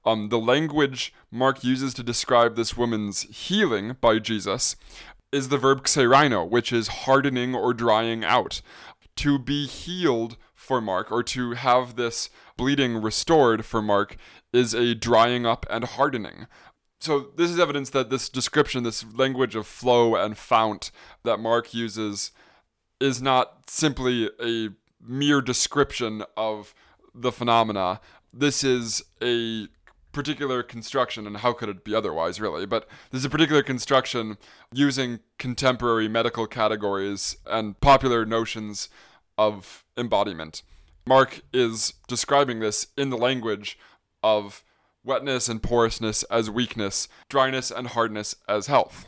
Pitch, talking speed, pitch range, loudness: 120 Hz, 135 wpm, 110-130 Hz, -24 LUFS